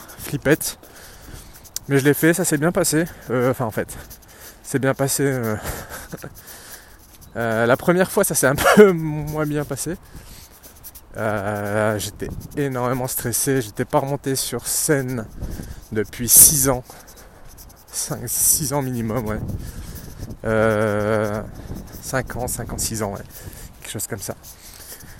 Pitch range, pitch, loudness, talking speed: 105-140 Hz, 120 Hz, -19 LUFS, 125 wpm